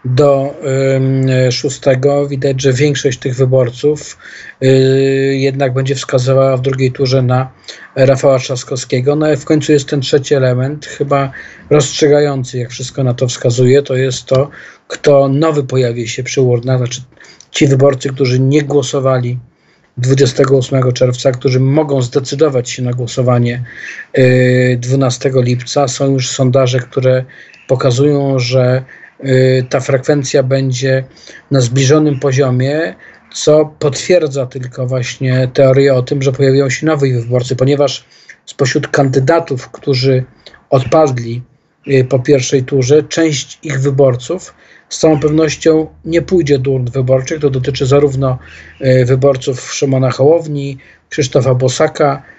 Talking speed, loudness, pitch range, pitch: 125 wpm, -12 LUFS, 130-145 Hz, 135 Hz